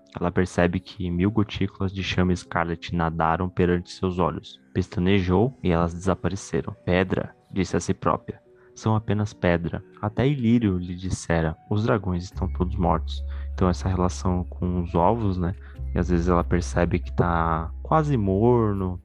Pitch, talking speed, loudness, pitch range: 90 Hz, 155 wpm, -25 LUFS, 85-100 Hz